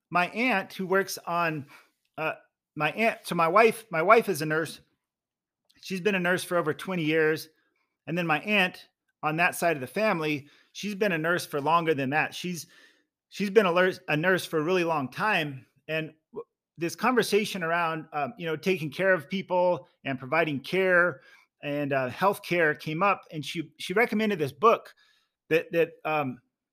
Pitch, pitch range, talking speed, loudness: 175 Hz, 155-195 Hz, 185 wpm, -27 LUFS